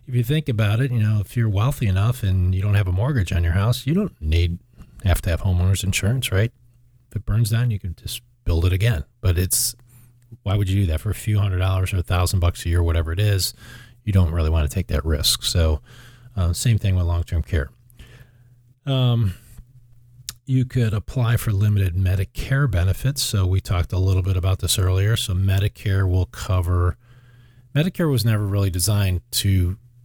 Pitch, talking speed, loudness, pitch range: 105 Hz, 205 wpm, -21 LUFS, 90-120 Hz